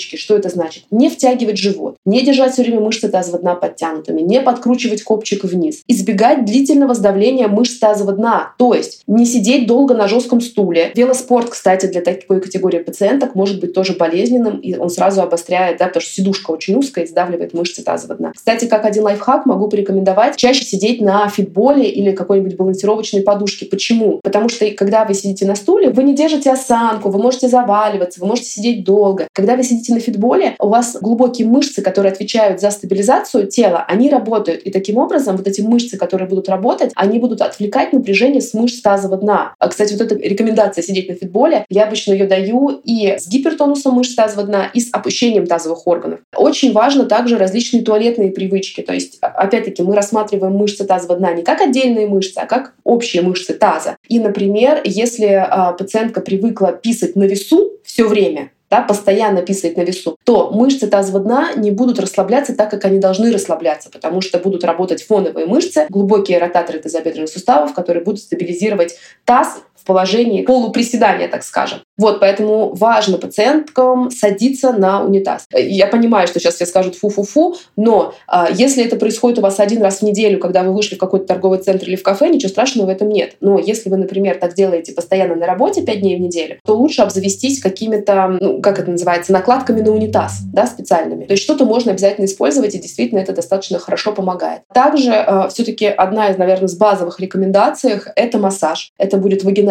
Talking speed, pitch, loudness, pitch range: 185 wpm, 205 Hz, -14 LUFS, 190-235 Hz